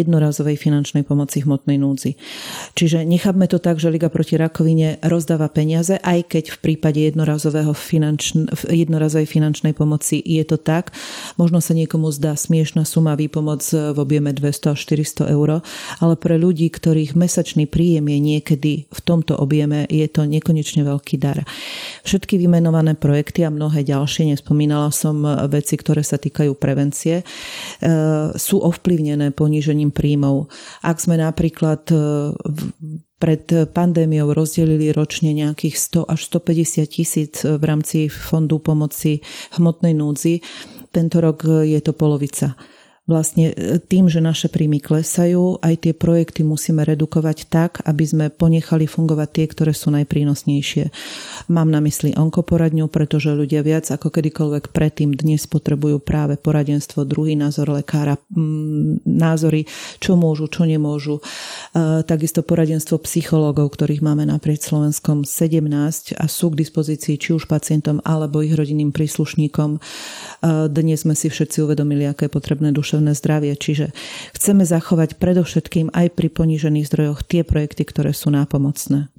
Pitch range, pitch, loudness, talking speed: 150-165 Hz, 155 Hz, -18 LUFS, 135 wpm